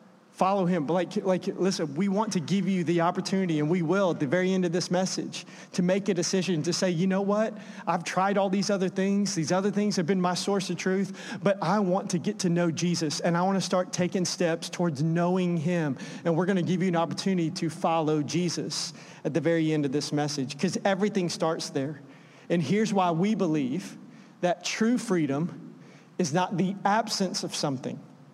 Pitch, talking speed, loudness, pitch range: 180 Hz, 215 wpm, -27 LUFS, 170-195 Hz